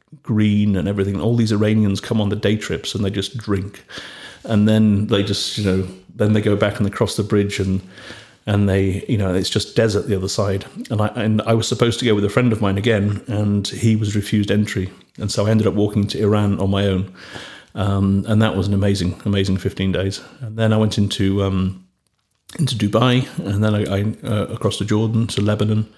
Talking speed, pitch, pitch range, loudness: 225 wpm, 105 Hz, 100-110 Hz, -19 LUFS